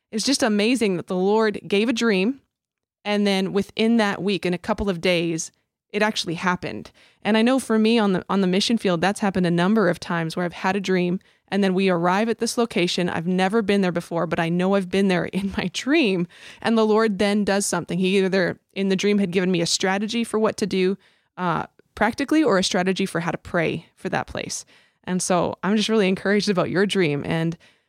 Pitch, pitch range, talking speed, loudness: 195 Hz, 180-215 Hz, 230 wpm, -22 LUFS